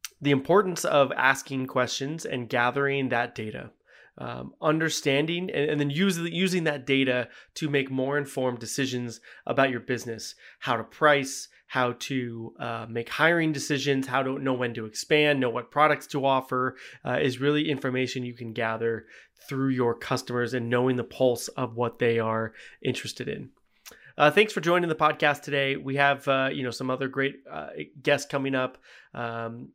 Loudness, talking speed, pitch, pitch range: -26 LUFS, 170 wpm, 135 Hz, 125-145 Hz